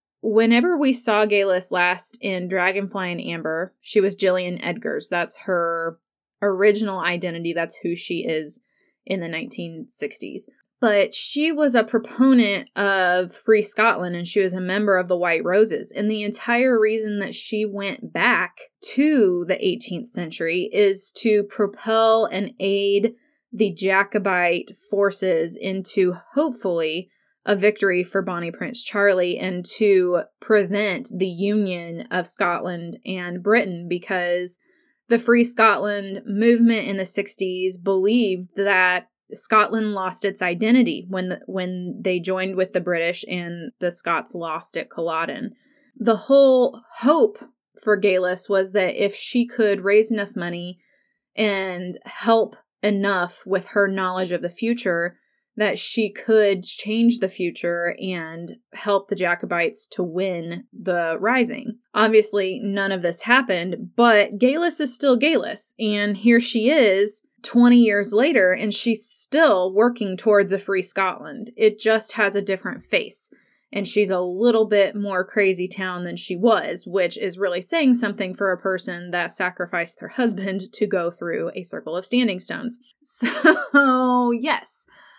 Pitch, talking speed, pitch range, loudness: 200 Hz, 145 wpm, 185-225 Hz, -21 LUFS